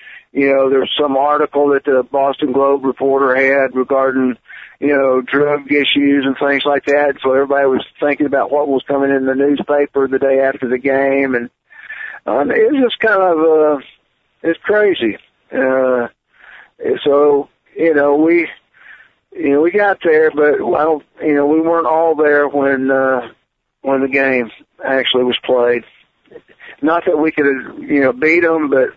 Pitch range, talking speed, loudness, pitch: 135-155 Hz, 170 wpm, -14 LUFS, 140 Hz